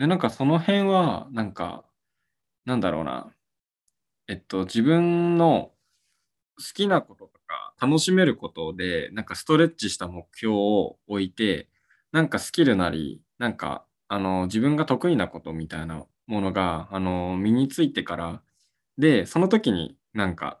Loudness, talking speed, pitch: -24 LUFS, 285 characters per minute, 115 Hz